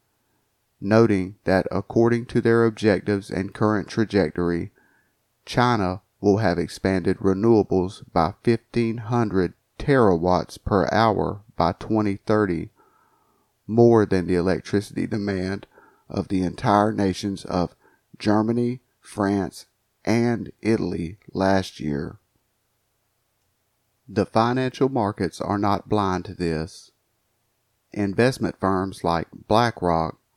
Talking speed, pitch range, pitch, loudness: 95 wpm, 95-115 Hz, 105 Hz, -23 LUFS